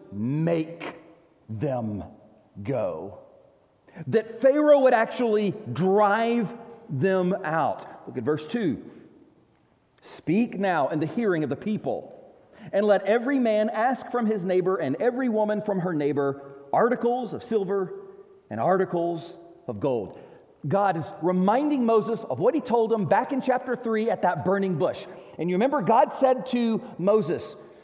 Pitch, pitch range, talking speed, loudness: 205 Hz, 170-235 Hz, 145 wpm, -25 LUFS